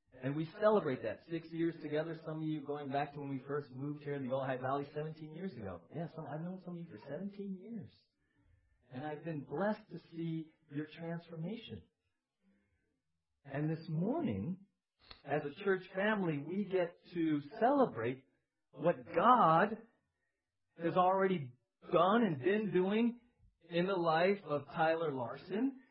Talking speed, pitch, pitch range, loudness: 160 wpm, 160 Hz, 145-185 Hz, -36 LUFS